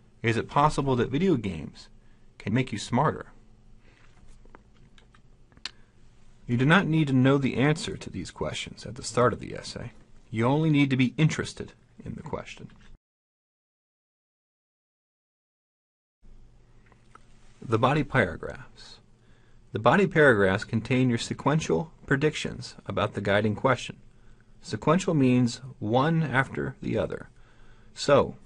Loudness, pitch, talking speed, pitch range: -26 LUFS, 120 Hz, 120 wpm, 110-140 Hz